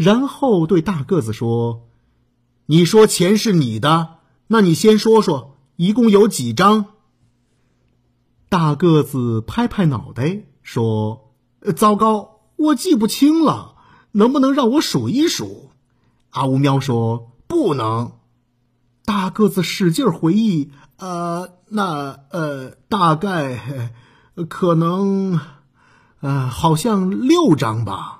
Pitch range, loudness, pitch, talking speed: 125-205 Hz, -17 LUFS, 165 Hz, 155 characters per minute